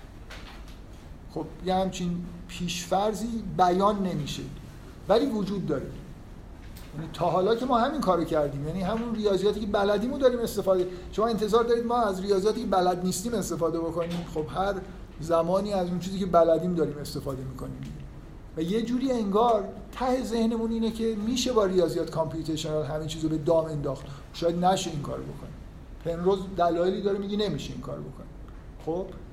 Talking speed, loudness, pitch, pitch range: 160 wpm, -27 LUFS, 185 Hz, 165-215 Hz